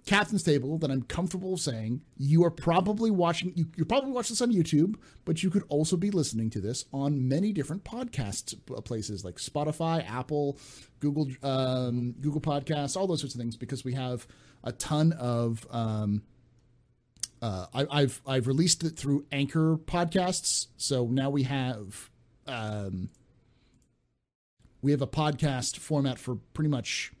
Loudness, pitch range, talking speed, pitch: -29 LUFS, 120-160 Hz, 155 wpm, 140 Hz